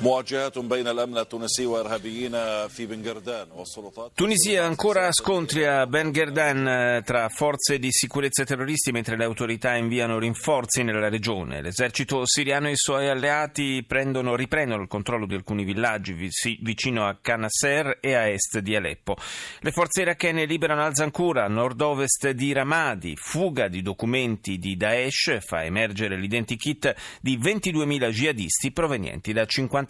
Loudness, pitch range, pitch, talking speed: -24 LUFS, 115-145 Hz, 125 Hz, 125 wpm